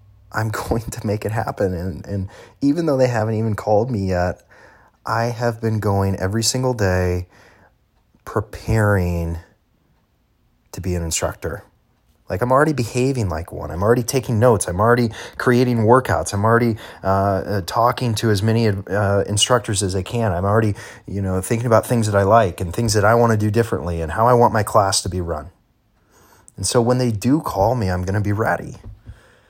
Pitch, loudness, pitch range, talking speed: 105 Hz, -19 LUFS, 95-115 Hz, 190 wpm